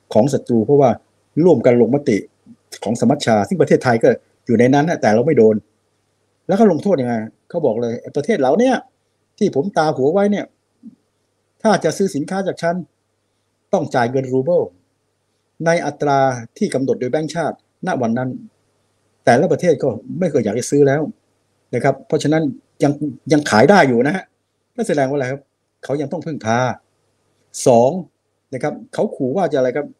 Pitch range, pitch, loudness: 115-160 Hz, 135 Hz, -17 LUFS